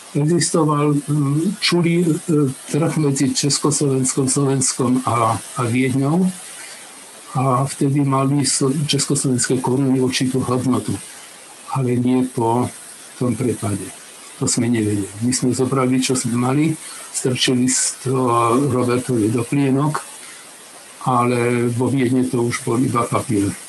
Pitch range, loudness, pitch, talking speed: 125-140 Hz, -18 LUFS, 130 Hz, 110 wpm